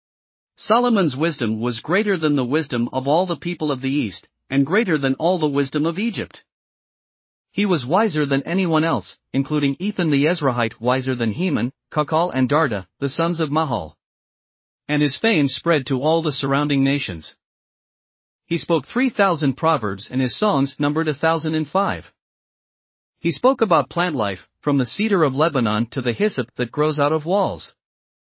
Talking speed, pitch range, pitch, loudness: 175 wpm, 135-170 Hz, 150 Hz, -20 LUFS